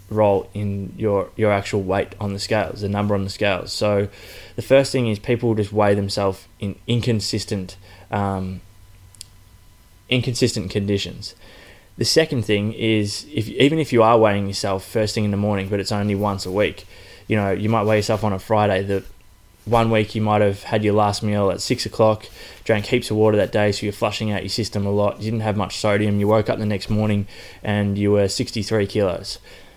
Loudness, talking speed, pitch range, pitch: -20 LUFS, 210 wpm, 100-110 Hz, 105 Hz